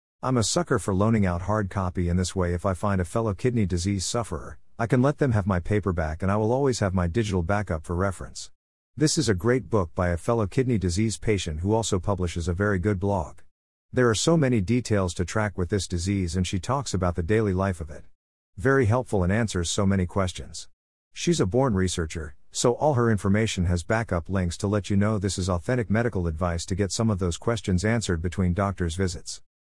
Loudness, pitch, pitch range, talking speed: -25 LUFS, 100 Hz, 90-110 Hz, 220 wpm